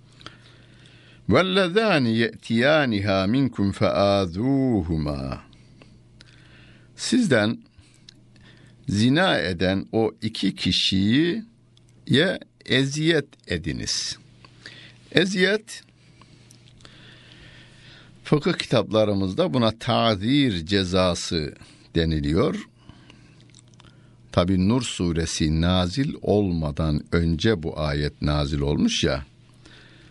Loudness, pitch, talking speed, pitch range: -22 LUFS, 105 Hz, 60 wpm, 90-125 Hz